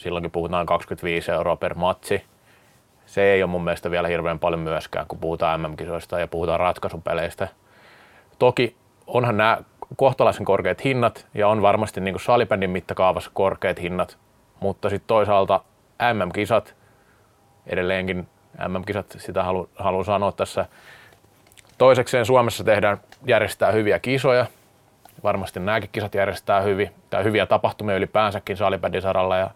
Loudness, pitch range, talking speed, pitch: -22 LUFS, 90-110 Hz, 130 wpm, 100 Hz